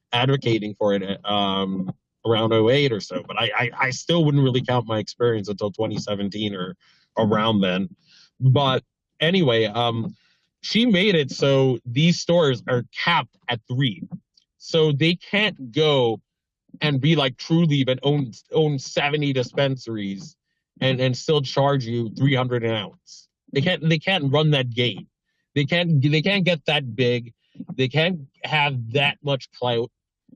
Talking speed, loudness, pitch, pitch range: 155 wpm, -22 LUFS, 135 Hz, 115-155 Hz